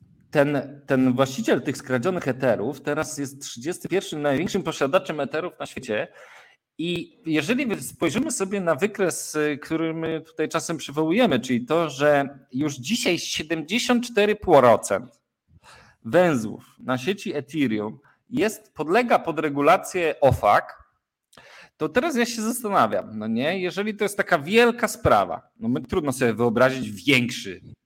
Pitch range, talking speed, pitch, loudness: 140-195 Hz, 125 wpm, 160 Hz, -23 LUFS